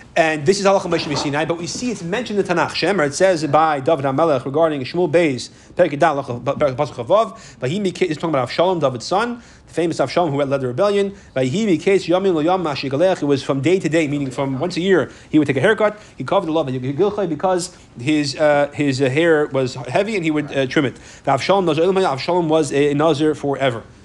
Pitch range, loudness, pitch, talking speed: 140-180 Hz, -18 LUFS, 160 Hz, 200 wpm